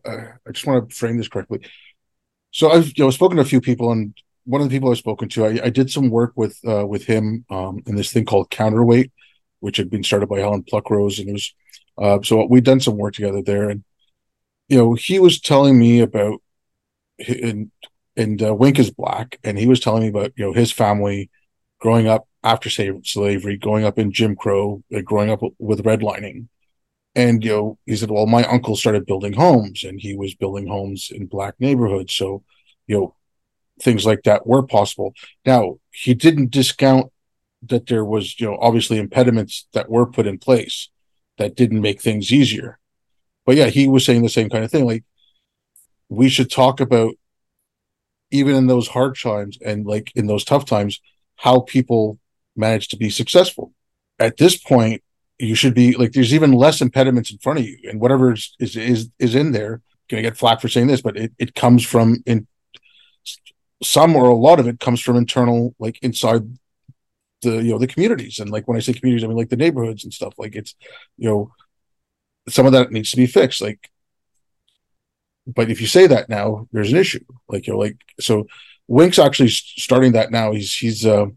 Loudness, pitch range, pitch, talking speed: -17 LUFS, 105-125 Hz, 115 Hz, 200 wpm